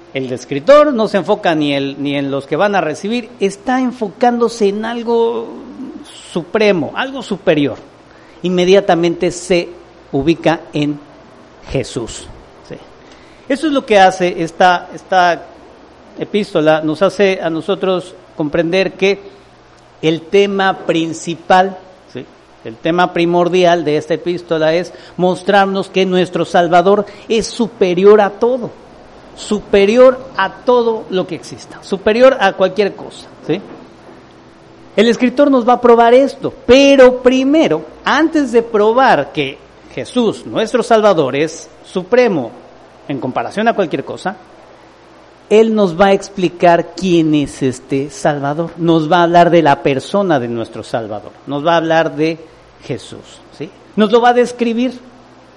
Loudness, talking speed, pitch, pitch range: -13 LUFS, 135 wpm, 185 Hz, 160-220 Hz